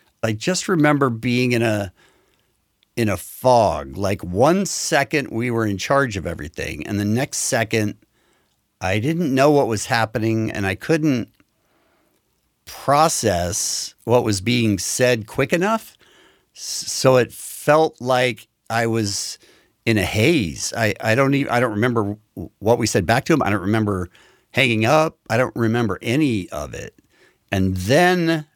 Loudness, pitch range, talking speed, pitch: -20 LUFS, 105-135 Hz, 155 wpm, 115 Hz